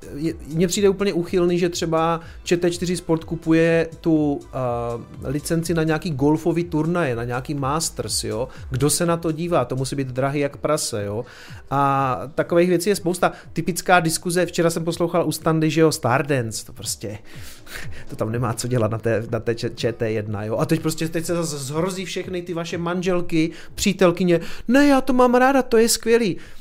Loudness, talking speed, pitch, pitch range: -21 LUFS, 180 wpm, 160 Hz, 135-175 Hz